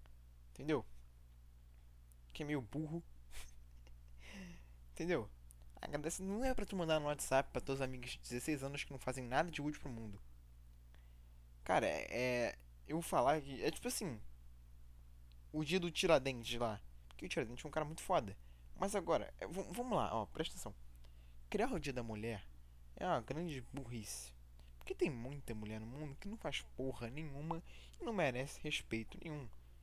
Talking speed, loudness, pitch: 170 wpm, -41 LUFS, 115 Hz